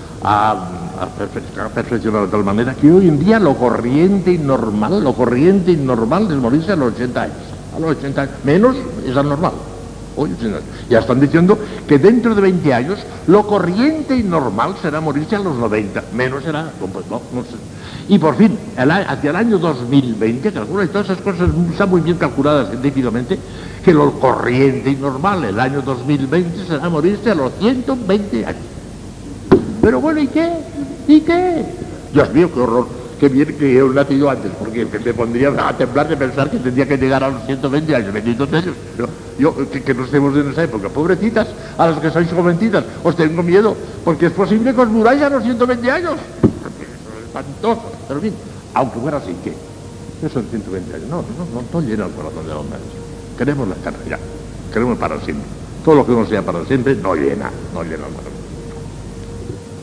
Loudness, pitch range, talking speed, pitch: -16 LUFS, 130-200 Hz, 190 wpm, 150 Hz